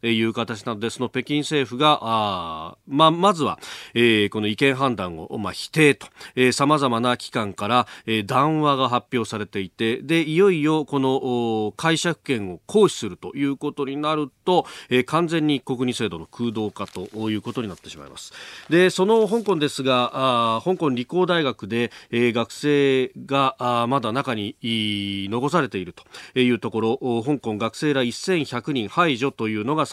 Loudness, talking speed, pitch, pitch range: -22 LUFS, 320 characters per minute, 125 Hz, 110-145 Hz